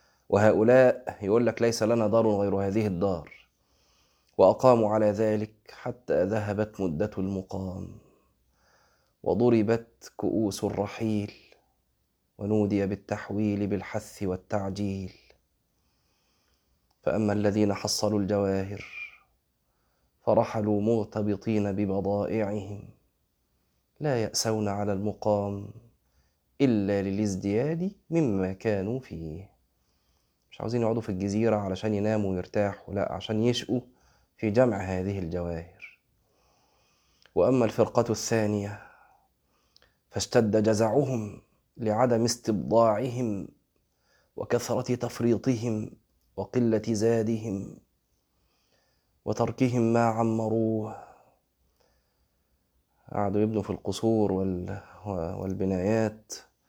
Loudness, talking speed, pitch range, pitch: -27 LUFS, 75 wpm, 95-115 Hz, 105 Hz